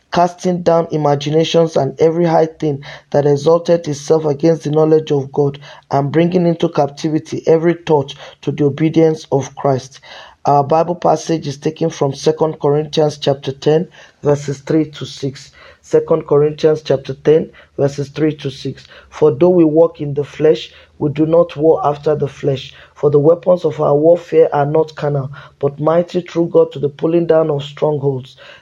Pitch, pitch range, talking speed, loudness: 155 Hz, 145-160 Hz, 170 wpm, -15 LUFS